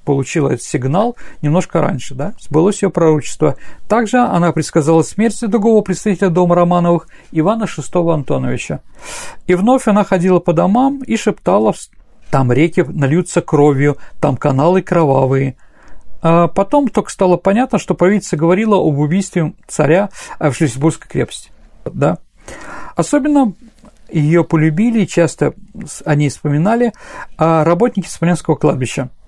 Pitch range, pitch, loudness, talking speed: 155-210 Hz, 175 Hz, -14 LUFS, 120 wpm